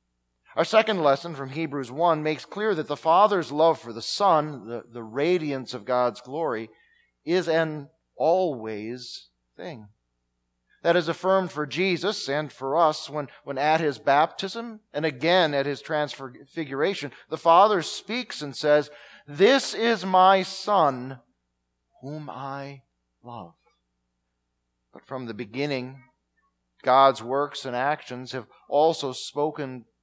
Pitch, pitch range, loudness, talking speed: 145 Hz, 125-165 Hz, -24 LUFS, 130 wpm